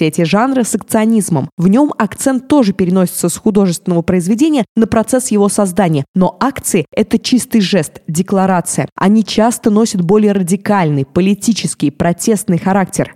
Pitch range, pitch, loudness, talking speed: 180-225 Hz, 200 Hz, -13 LUFS, 135 wpm